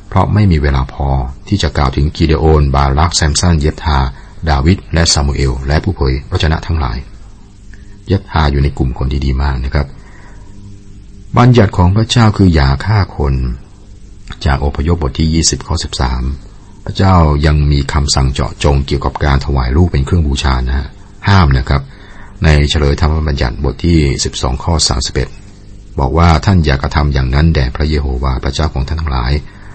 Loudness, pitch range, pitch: -13 LUFS, 70-95 Hz, 75 Hz